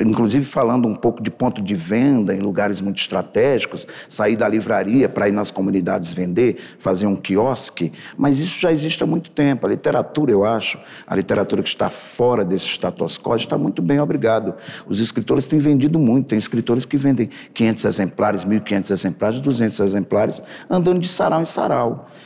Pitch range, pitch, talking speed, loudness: 100-145 Hz, 120 Hz, 180 wpm, -19 LUFS